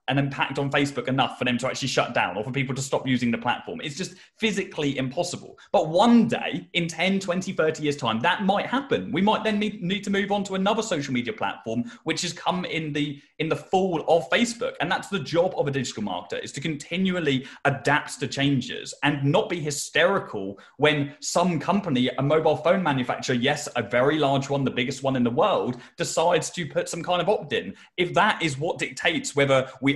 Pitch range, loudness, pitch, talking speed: 135-180 Hz, -25 LUFS, 150 Hz, 215 wpm